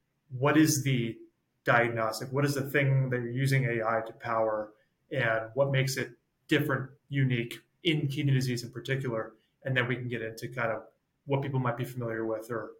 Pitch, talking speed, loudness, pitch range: 125 Hz, 190 wpm, -30 LUFS, 115-140 Hz